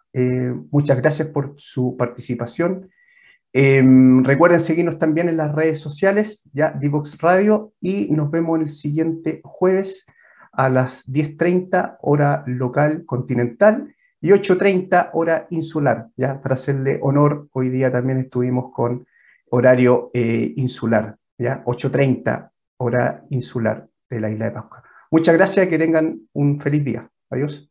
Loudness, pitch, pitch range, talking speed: -19 LUFS, 145 Hz, 125-165 Hz, 135 wpm